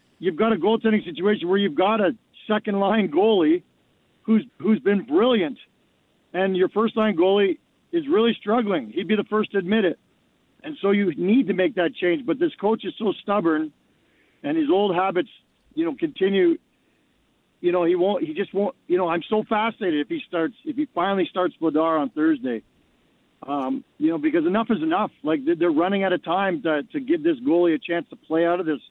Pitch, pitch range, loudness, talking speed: 210 Hz, 185-290 Hz, -22 LUFS, 205 wpm